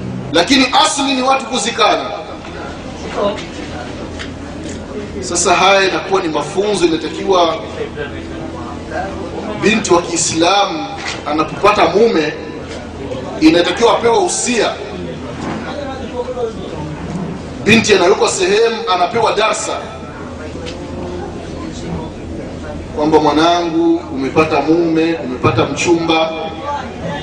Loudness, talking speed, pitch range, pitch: -15 LUFS, 65 wpm, 150-230 Hz, 170 Hz